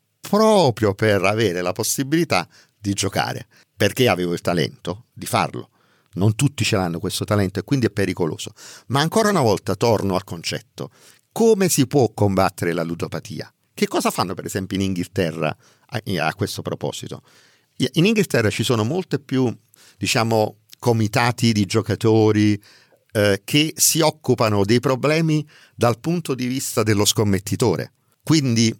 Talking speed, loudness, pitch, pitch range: 145 wpm, -20 LUFS, 110 Hz, 100-135 Hz